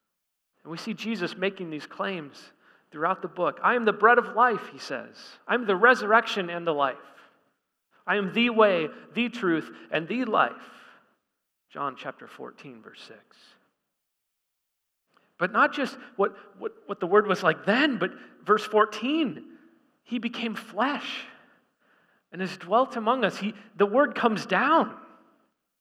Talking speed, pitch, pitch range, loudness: 150 wpm, 215 Hz, 190-245 Hz, -25 LUFS